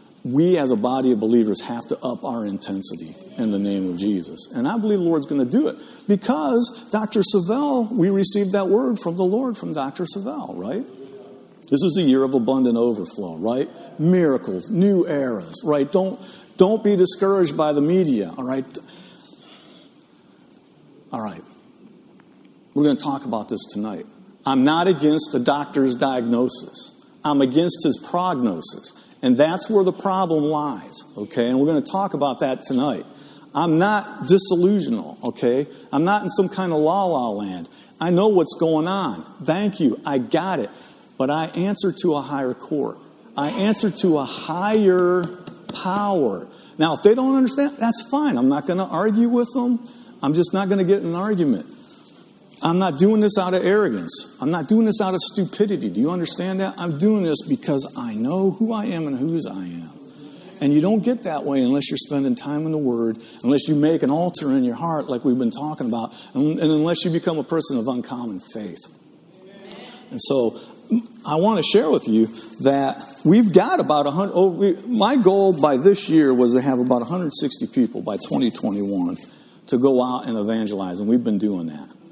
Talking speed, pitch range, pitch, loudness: 185 wpm, 140-205 Hz, 175 Hz, -20 LUFS